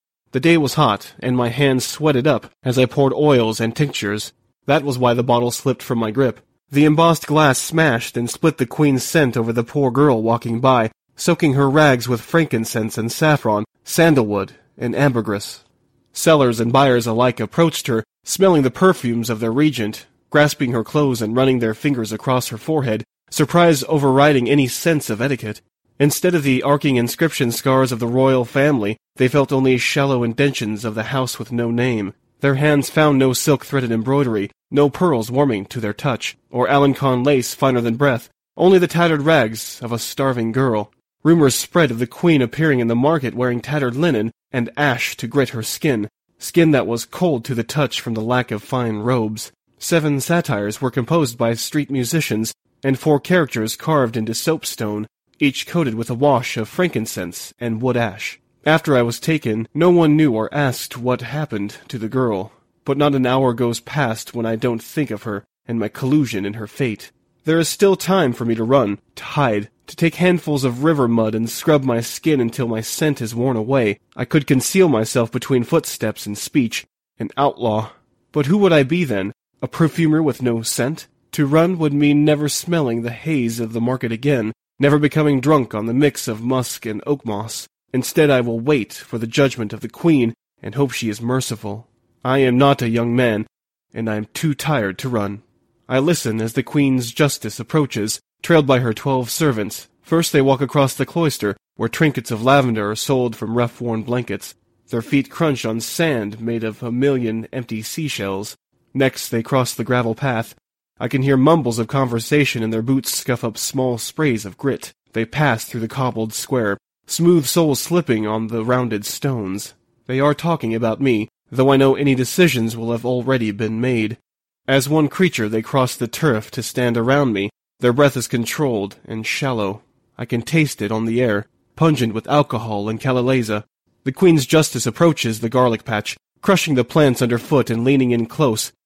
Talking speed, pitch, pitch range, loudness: 190 wpm, 125 Hz, 115-145 Hz, -18 LUFS